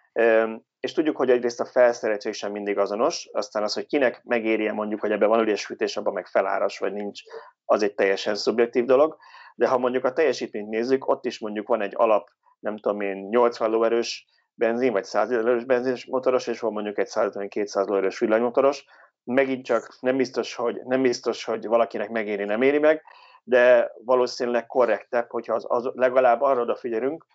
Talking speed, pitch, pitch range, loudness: 180 wpm, 120 Hz, 105-130 Hz, -24 LUFS